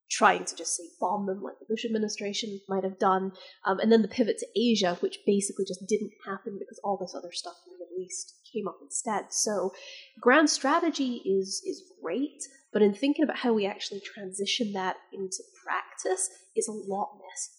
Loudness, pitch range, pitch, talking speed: -29 LUFS, 190-240 Hz, 200 Hz, 200 wpm